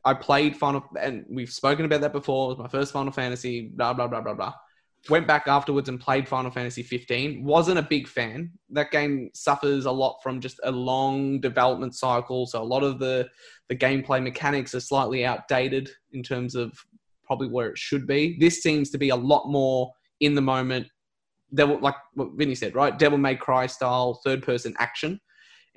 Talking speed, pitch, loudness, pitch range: 200 wpm, 135 Hz, -25 LUFS, 125-145 Hz